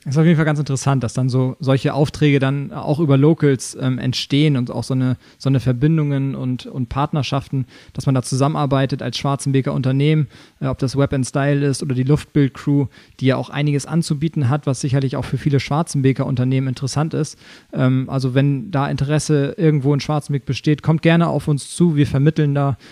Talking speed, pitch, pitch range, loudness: 205 wpm, 140 Hz, 130-150 Hz, -18 LUFS